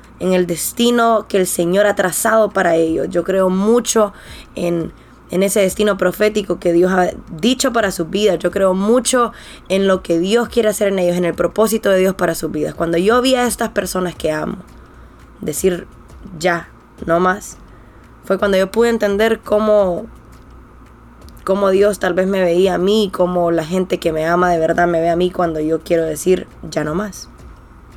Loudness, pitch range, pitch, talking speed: -16 LUFS, 175-210 Hz, 185 Hz, 190 wpm